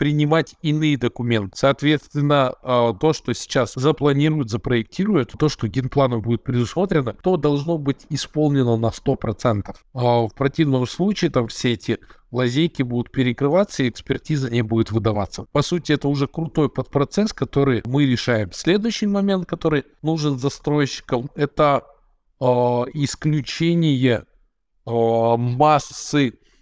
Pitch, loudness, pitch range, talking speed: 140 Hz, -20 LUFS, 120-150 Hz, 115 wpm